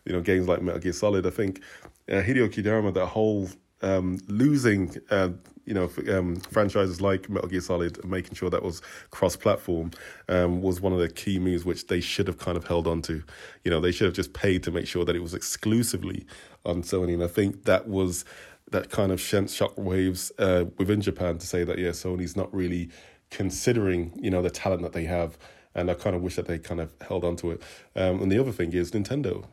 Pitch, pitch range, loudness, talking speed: 90 Hz, 85-95 Hz, -27 LUFS, 230 wpm